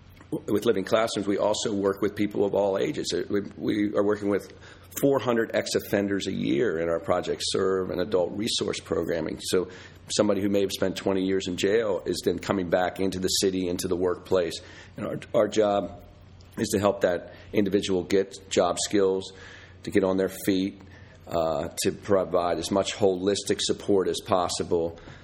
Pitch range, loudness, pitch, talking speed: 95-100 Hz, -26 LUFS, 95 Hz, 180 wpm